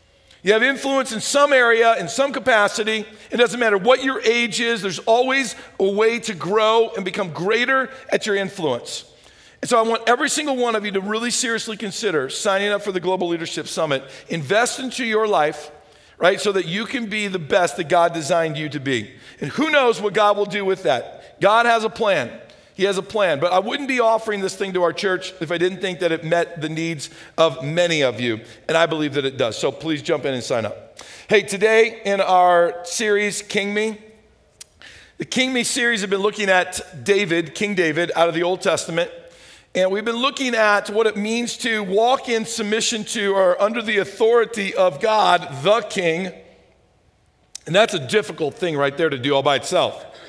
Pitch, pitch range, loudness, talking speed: 205 Hz, 175-230 Hz, -19 LUFS, 210 wpm